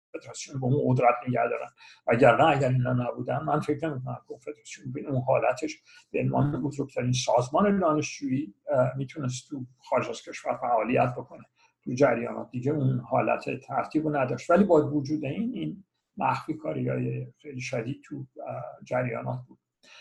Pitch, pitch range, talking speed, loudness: 135 Hz, 125-150 Hz, 155 wpm, -27 LUFS